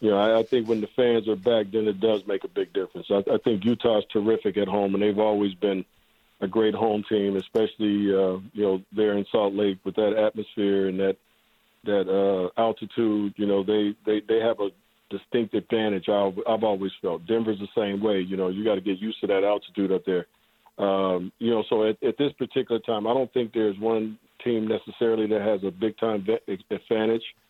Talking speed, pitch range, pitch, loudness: 210 wpm, 100-115 Hz, 105 Hz, -25 LUFS